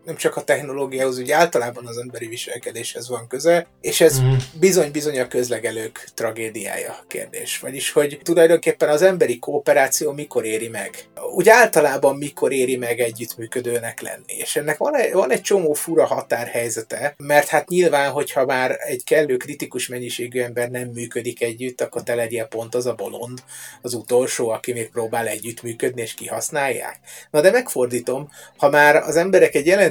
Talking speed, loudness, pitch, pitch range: 160 wpm, -20 LUFS, 125 Hz, 120-150 Hz